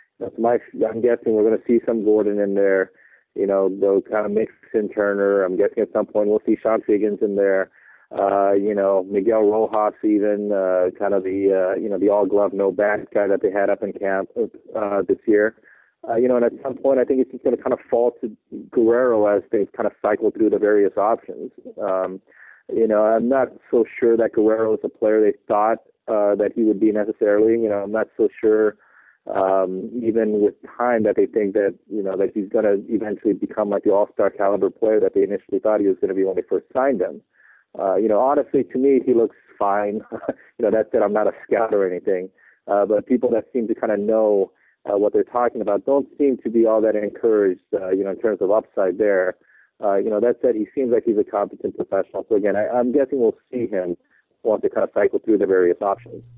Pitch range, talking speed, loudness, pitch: 100-140 Hz, 235 wpm, -20 LUFS, 110 Hz